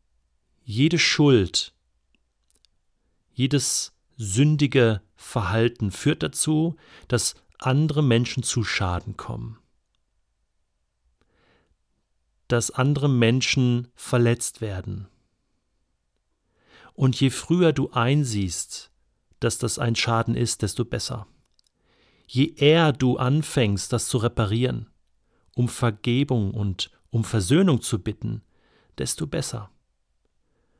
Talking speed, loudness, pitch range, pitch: 90 wpm, -23 LUFS, 105-135 Hz, 120 Hz